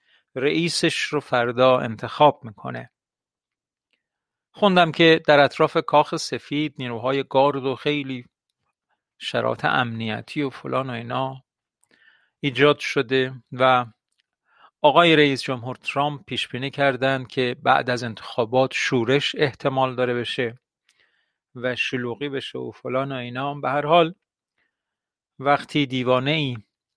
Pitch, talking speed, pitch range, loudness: 130 Hz, 115 wpm, 125-145 Hz, -21 LUFS